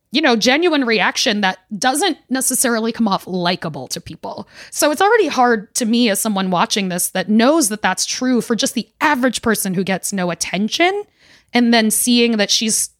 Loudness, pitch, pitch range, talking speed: -16 LUFS, 230 Hz, 195-260 Hz, 190 wpm